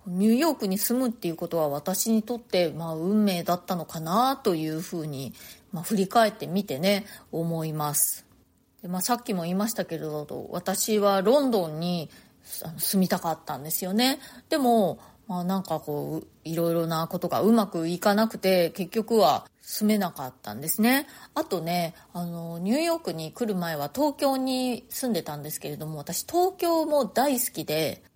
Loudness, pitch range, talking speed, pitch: -26 LUFS, 165-225 Hz, 340 characters per minute, 185 Hz